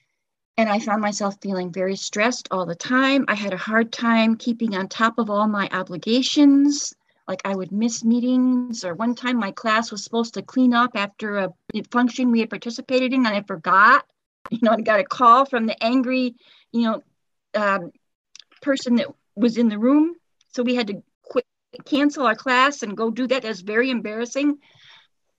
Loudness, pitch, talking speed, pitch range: -21 LUFS, 230 Hz, 190 wpm, 210-255 Hz